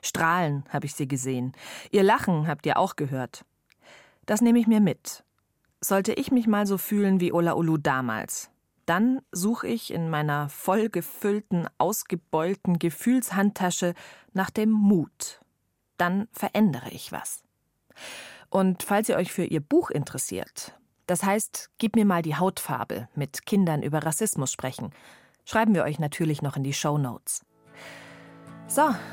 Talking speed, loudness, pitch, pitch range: 145 wpm, -26 LUFS, 180 Hz, 150-205 Hz